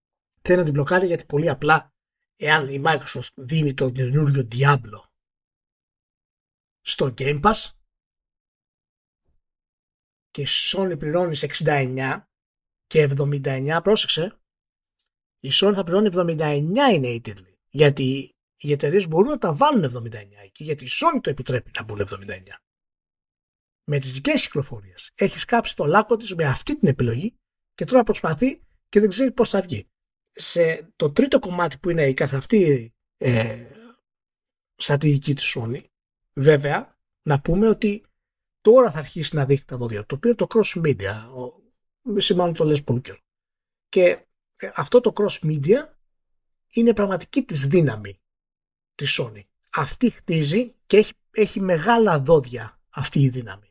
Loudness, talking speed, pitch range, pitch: -21 LUFS, 145 wpm, 120-195 Hz, 150 Hz